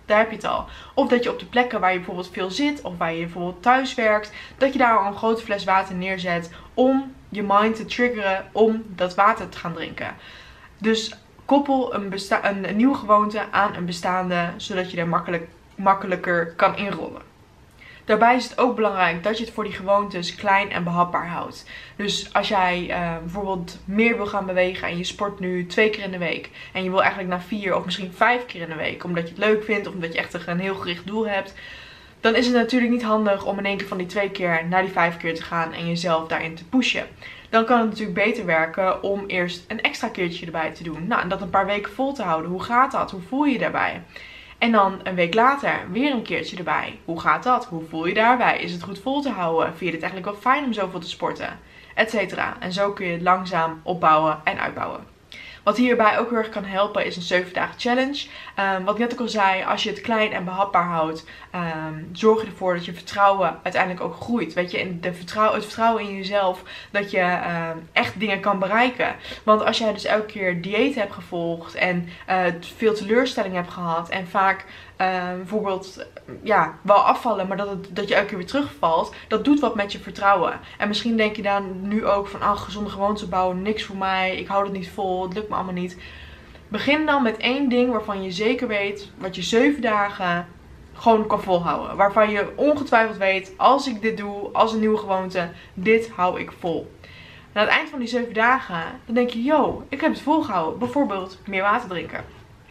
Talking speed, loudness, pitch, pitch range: 225 wpm, -22 LUFS, 200 Hz, 180-220 Hz